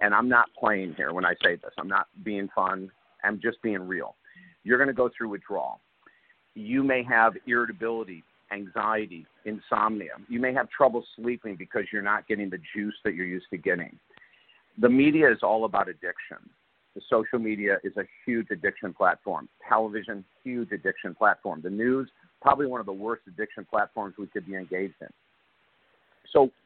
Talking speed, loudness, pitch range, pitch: 175 wpm, -27 LUFS, 100-120 Hz, 110 Hz